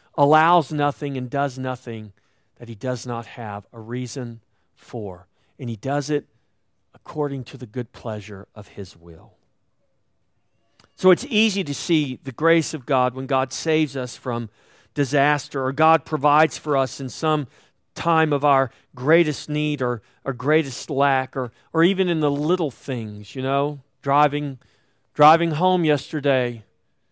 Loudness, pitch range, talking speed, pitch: -22 LUFS, 115-150 Hz, 155 wpm, 135 Hz